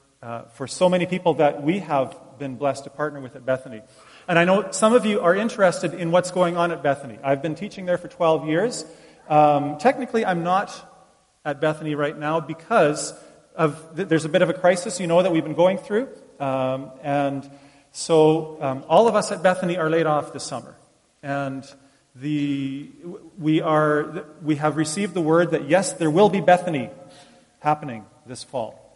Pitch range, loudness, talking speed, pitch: 140-180 Hz, -22 LUFS, 190 wpm, 160 Hz